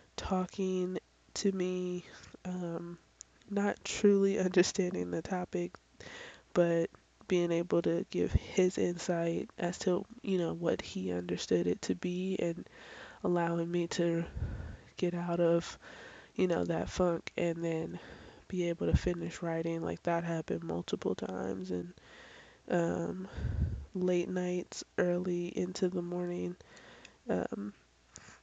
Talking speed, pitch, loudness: 120 wpm, 170 Hz, -34 LUFS